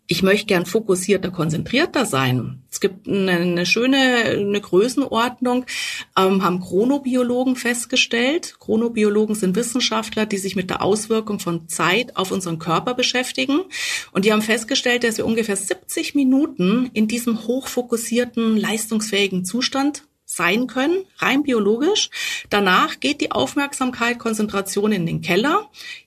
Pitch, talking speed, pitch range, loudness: 230 Hz, 125 wpm, 195-260 Hz, -19 LUFS